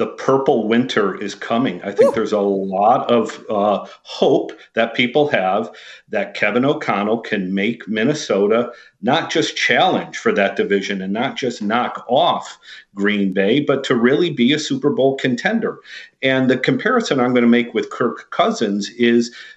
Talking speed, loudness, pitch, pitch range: 165 wpm, -18 LUFS, 120 Hz, 100-130 Hz